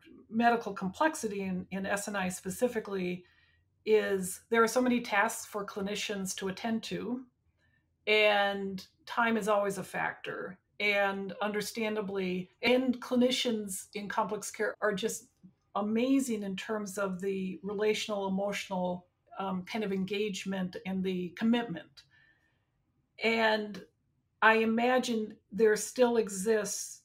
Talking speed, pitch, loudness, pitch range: 115 wpm, 205 Hz, -31 LUFS, 195-225 Hz